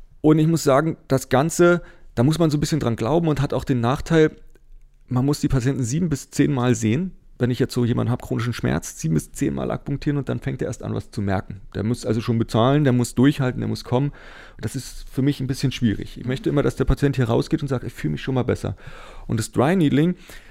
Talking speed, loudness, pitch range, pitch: 255 wpm, -22 LUFS, 120-145 Hz, 130 Hz